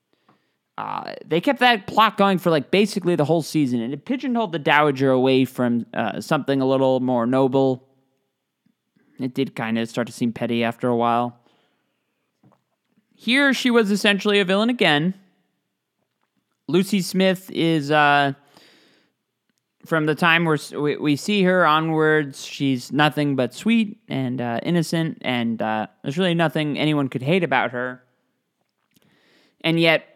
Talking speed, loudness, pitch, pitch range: 150 wpm, -20 LUFS, 150 Hz, 130-190 Hz